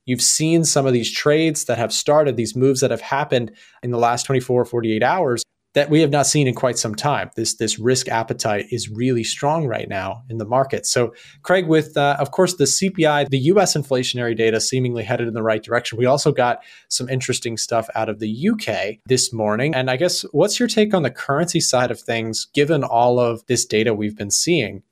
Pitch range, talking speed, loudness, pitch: 115-145 Hz, 220 wpm, -19 LUFS, 125 Hz